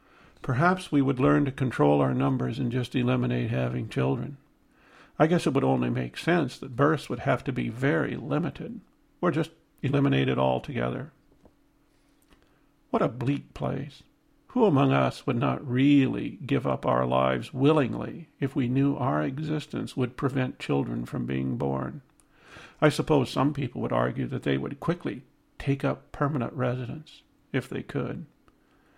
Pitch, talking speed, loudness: 130 Hz, 155 wpm, -27 LUFS